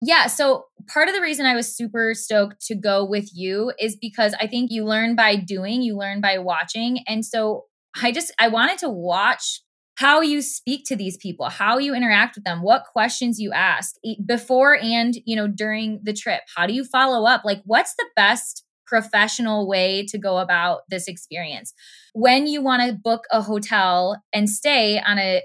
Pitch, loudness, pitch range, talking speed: 225 Hz, -20 LUFS, 205-250 Hz, 195 wpm